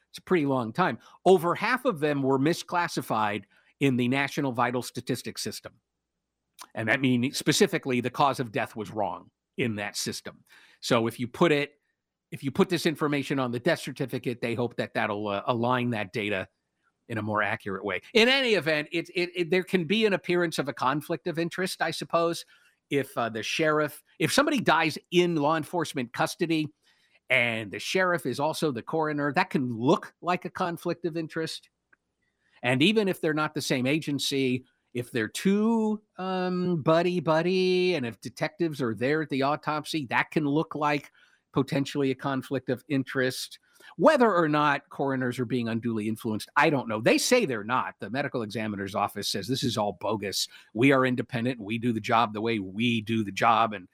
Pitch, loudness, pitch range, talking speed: 145 Hz, -27 LUFS, 125-170 Hz, 190 wpm